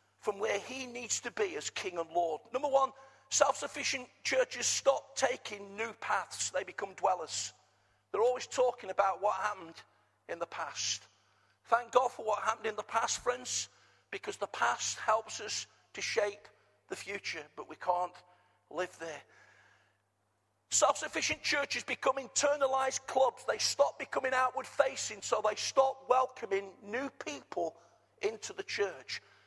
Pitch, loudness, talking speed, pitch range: 245 Hz, -33 LUFS, 150 wpm, 195-270 Hz